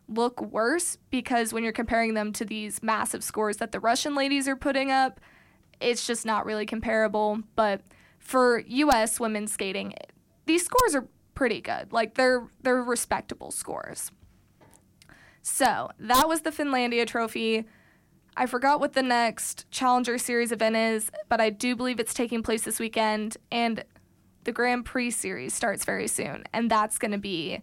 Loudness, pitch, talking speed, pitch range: -27 LUFS, 235 Hz, 165 wpm, 220-255 Hz